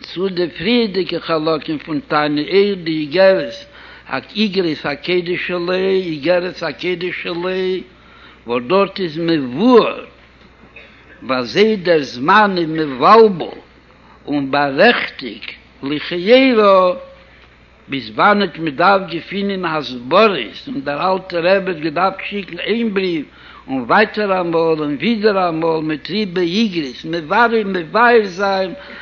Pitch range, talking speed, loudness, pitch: 160-200 Hz, 120 wpm, -16 LUFS, 180 Hz